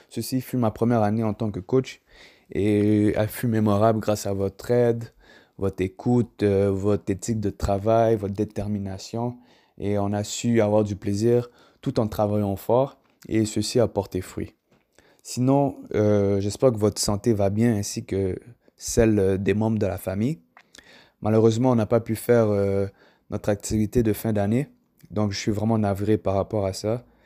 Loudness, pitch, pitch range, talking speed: -24 LUFS, 105 Hz, 100-115 Hz, 170 wpm